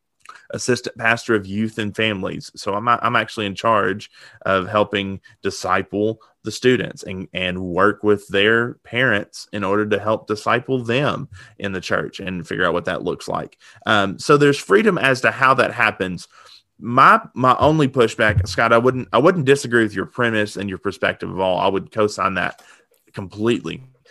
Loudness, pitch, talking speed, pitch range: -19 LUFS, 110 Hz, 175 wpm, 100-120 Hz